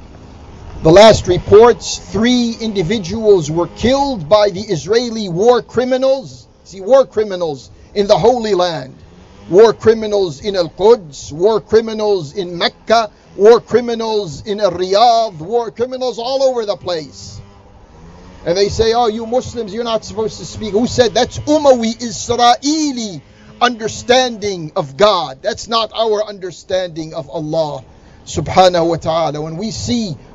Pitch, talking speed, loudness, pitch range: 210 Hz, 135 wpm, -14 LUFS, 170-235 Hz